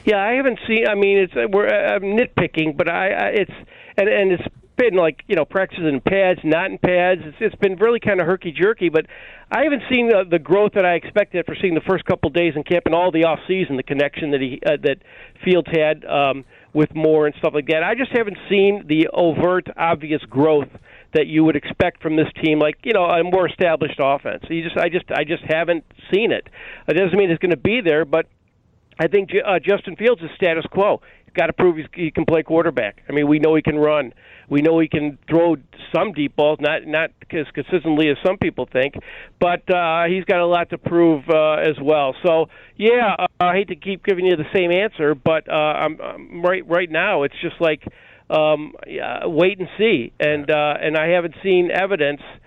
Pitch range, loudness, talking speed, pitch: 155-185 Hz, -19 LUFS, 225 wpm, 170 Hz